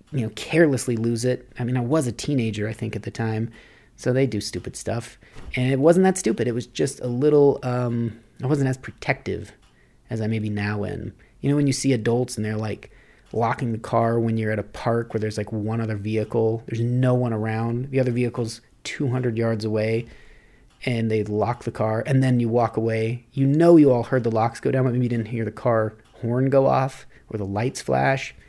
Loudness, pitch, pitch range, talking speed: -23 LUFS, 115 Hz, 110-125 Hz, 225 wpm